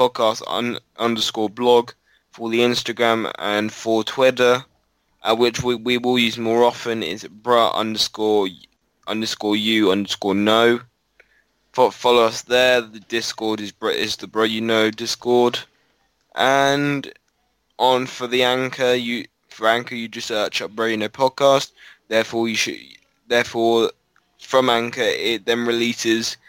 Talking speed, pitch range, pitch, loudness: 145 wpm, 110-125 Hz, 115 Hz, -19 LUFS